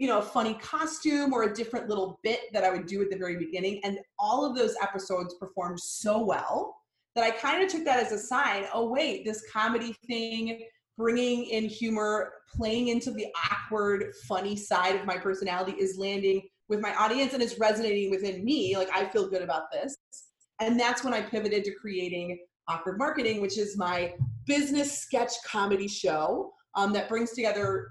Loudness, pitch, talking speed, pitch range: -29 LUFS, 215 Hz, 190 wpm, 195-240 Hz